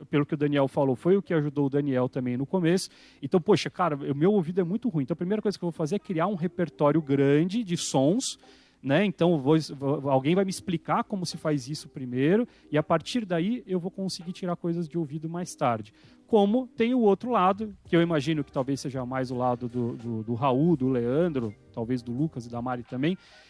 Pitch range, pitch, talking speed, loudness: 140-185 Hz, 160 Hz, 230 wpm, -27 LUFS